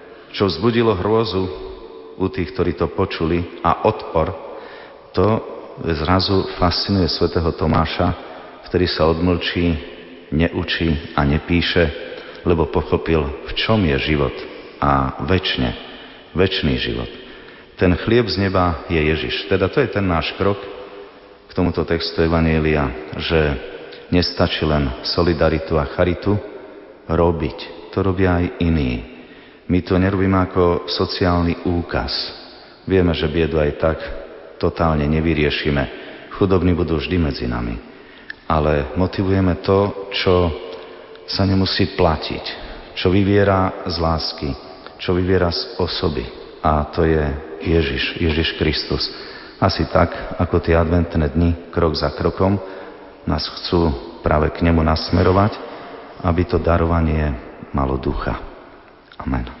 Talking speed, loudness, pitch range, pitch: 120 wpm, -19 LUFS, 80-95 Hz, 85 Hz